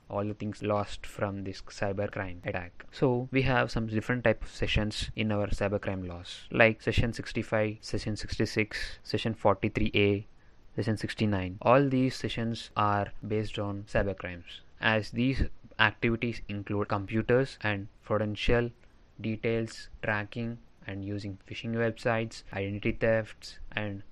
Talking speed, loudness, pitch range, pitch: 135 wpm, -31 LUFS, 100-115 Hz, 105 Hz